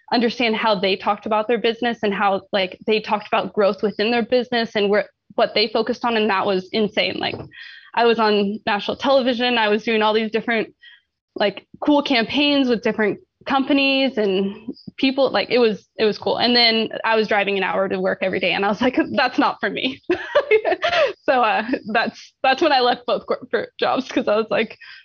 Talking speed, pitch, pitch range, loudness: 205 wpm, 225 Hz, 210-260 Hz, -19 LUFS